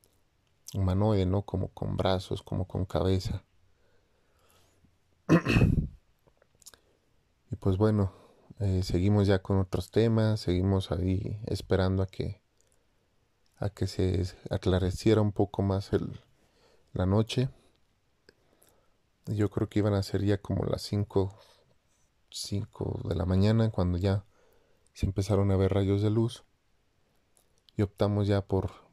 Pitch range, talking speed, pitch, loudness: 95-105 Hz, 125 wpm, 100 Hz, -29 LUFS